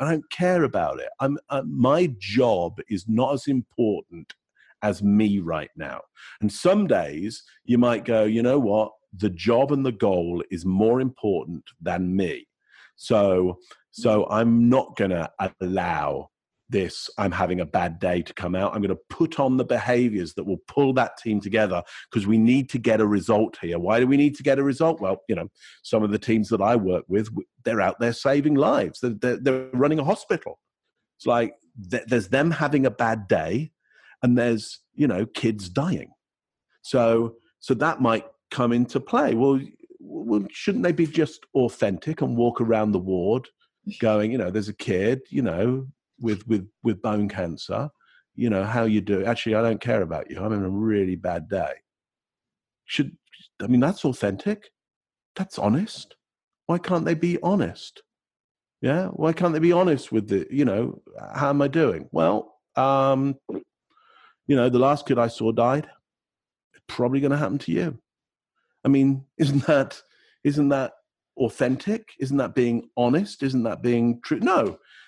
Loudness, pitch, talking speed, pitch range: -23 LUFS, 125 Hz, 175 wpm, 110-145 Hz